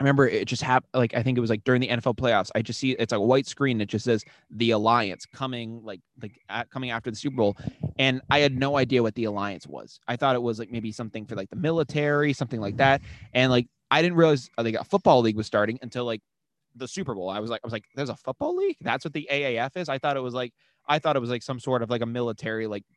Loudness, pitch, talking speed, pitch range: -25 LUFS, 125 Hz, 280 wpm, 115-135 Hz